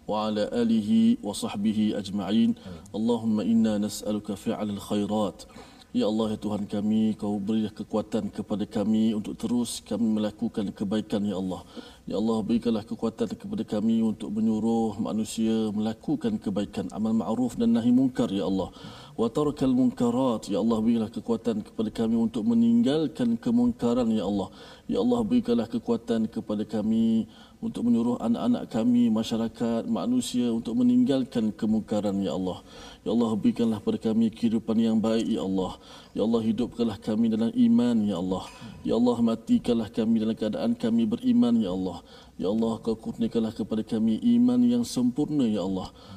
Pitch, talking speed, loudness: 230 Hz, 150 wpm, -26 LUFS